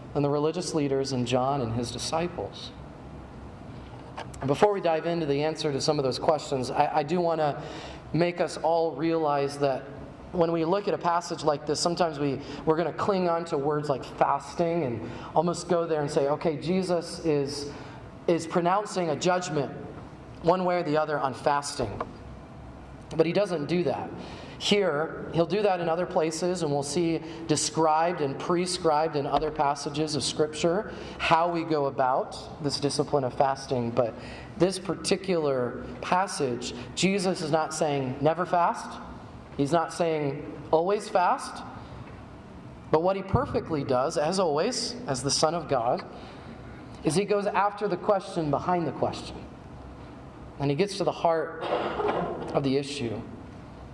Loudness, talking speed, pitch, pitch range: -27 LUFS, 160 wpm, 155 Hz, 140-170 Hz